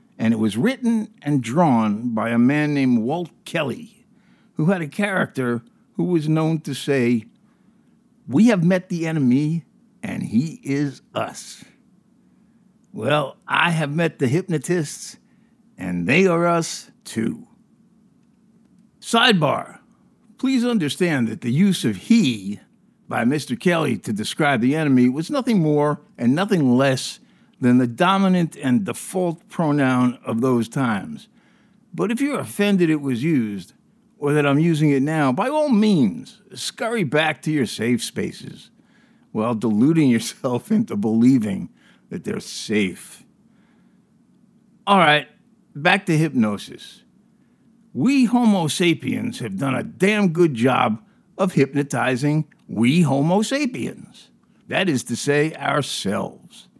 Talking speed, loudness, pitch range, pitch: 130 wpm, -20 LUFS, 135-220 Hz, 175 Hz